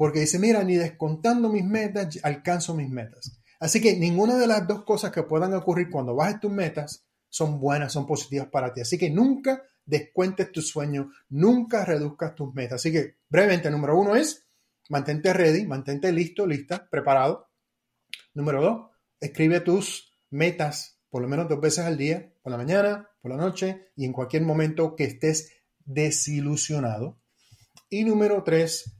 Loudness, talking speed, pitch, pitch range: -25 LUFS, 165 wpm, 160 Hz, 145-190 Hz